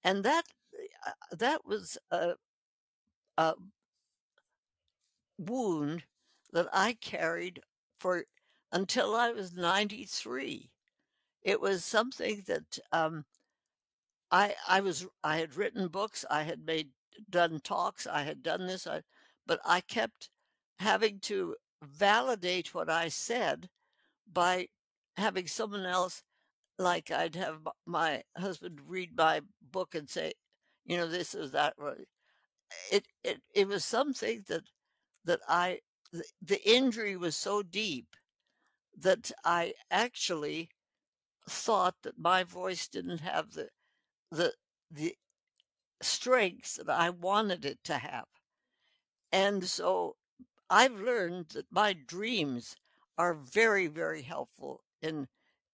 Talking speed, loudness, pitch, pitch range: 120 wpm, -32 LUFS, 190 Hz, 170-230 Hz